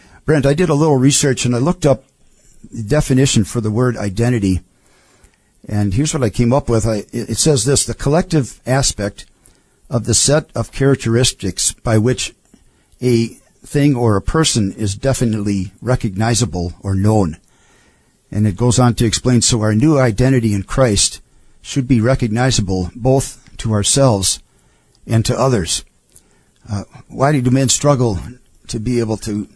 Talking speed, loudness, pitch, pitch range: 155 wpm, -16 LUFS, 120 Hz, 105-135 Hz